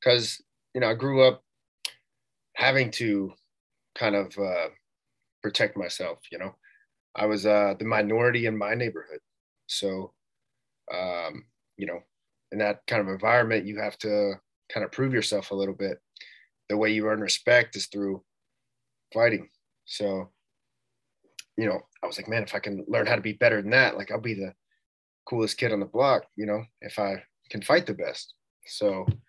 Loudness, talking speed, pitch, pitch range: -26 LUFS, 175 wpm, 105 Hz, 100-120 Hz